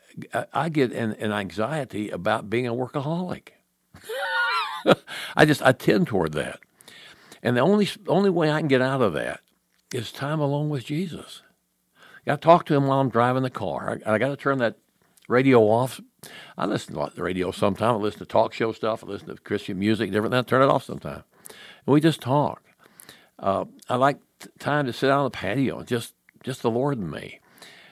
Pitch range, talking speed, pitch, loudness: 110-145 Hz, 205 wpm, 130 Hz, -24 LUFS